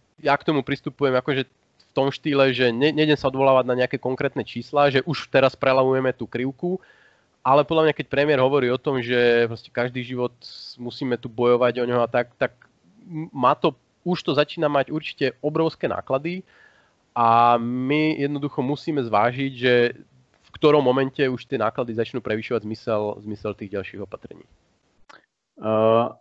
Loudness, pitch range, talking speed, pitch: -22 LUFS, 120-145 Hz, 160 wpm, 130 Hz